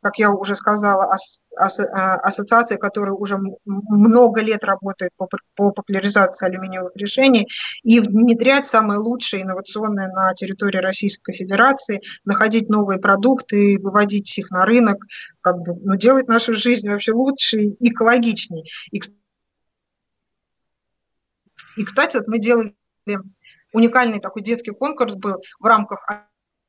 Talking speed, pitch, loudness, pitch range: 130 wpm, 205 Hz, -18 LUFS, 195-230 Hz